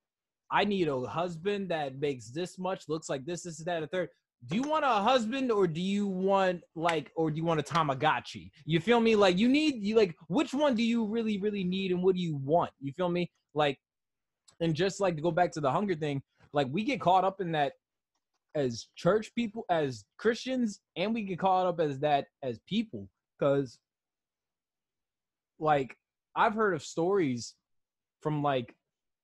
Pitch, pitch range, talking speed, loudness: 175 Hz, 150-205 Hz, 195 wpm, -30 LUFS